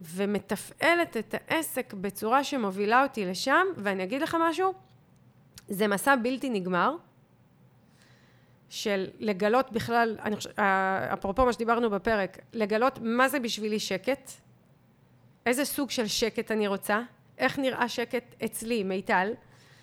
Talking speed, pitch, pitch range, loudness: 120 wpm, 230 Hz, 200-260 Hz, -28 LUFS